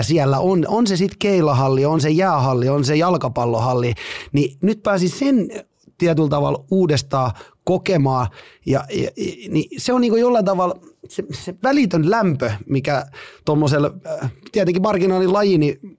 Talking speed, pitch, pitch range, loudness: 145 wpm, 165 Hz, 140-195 Hz, -19 LUFS